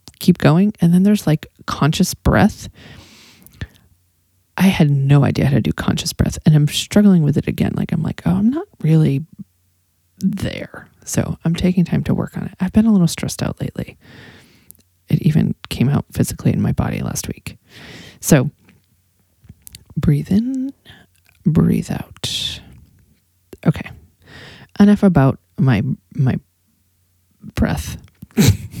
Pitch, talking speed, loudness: 145 Hz, 140 wpm, -17 LUFS